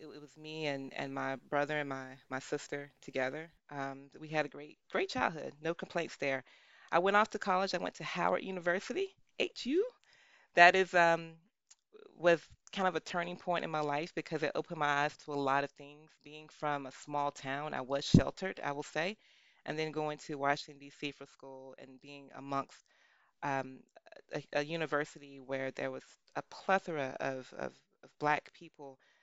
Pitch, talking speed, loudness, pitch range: 150 Hz, 190 wpm, -35 LUFS, 140-170 Hz